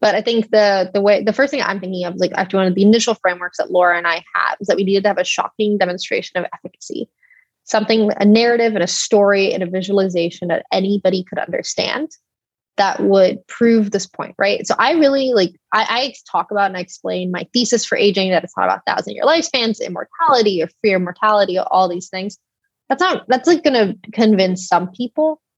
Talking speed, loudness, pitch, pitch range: 215 wpm, -16 LUFS, 200 Hz, 185-230 Hz